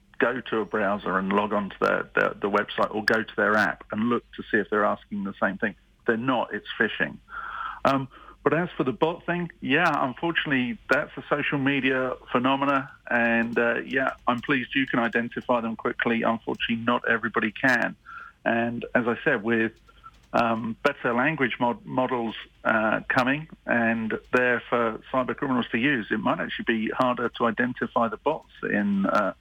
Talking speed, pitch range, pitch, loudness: 180 wpm, 115-140 Hz, 125 Hz, -25 LUFS